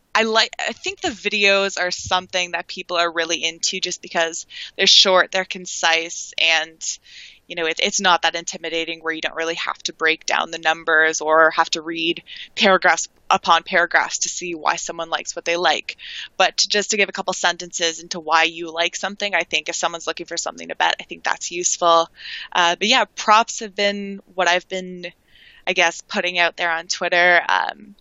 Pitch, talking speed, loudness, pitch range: 175 Hz, 205 wpm, -19 LUFS, 165-190 Hz